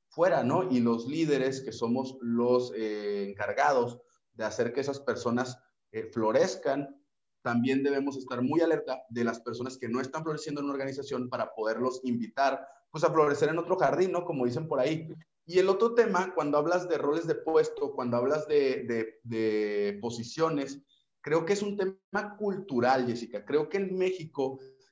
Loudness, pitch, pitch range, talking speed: -30 LUFS, 135 Hz, 120-165 Hz, 175 wpm